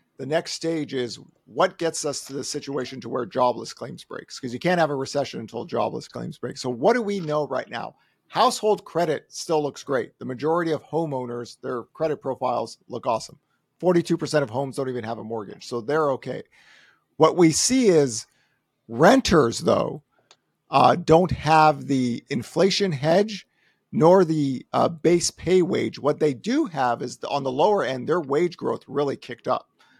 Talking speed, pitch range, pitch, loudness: 180 wpm, 130-170 Hz, 150 Hz, -23 LUFS